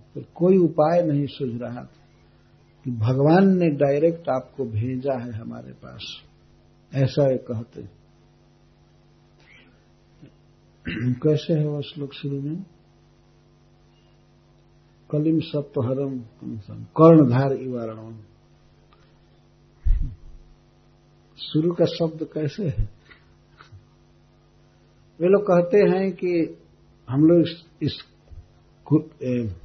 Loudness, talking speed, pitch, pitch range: -22 LUFS, 90 wpm, 145 Hz, 125-160 Hz